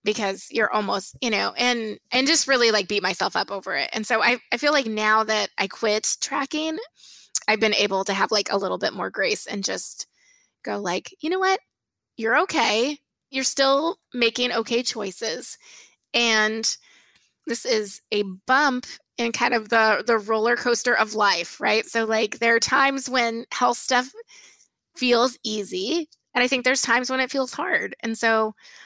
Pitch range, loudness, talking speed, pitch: 220-270 Hz, -22 LUFS, 180 wpm, 235 Hz